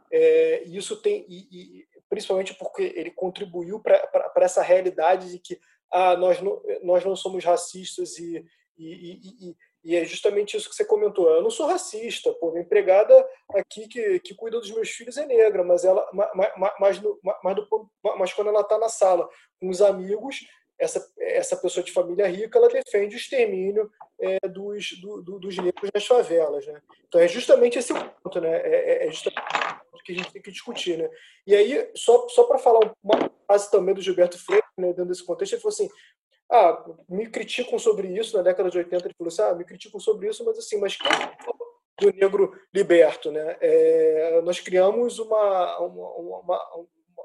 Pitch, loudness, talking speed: 235 Hz, -23 LUFS, 190 wpm